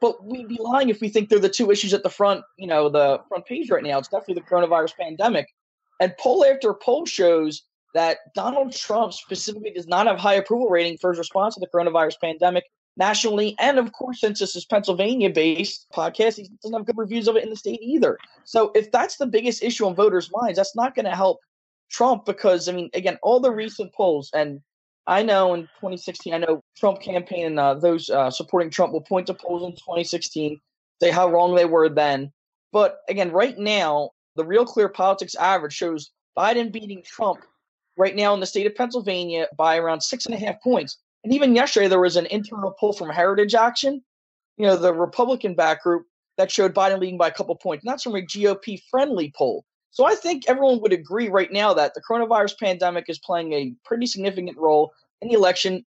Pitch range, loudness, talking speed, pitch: 175-225 Hz, -21 LUFS, 210 wpm, 195 Hz